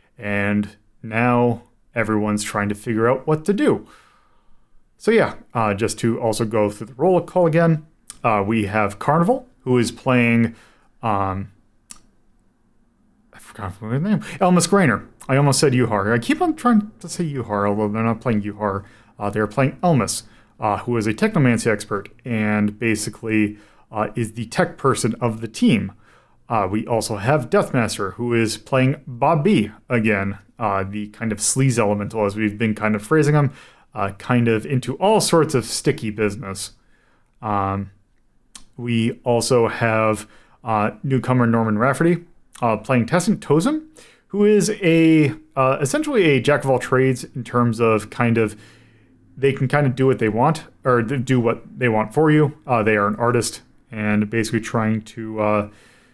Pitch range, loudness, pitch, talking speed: 110-140 Hz, -20 LUFS, 115 Hz, 165 wpm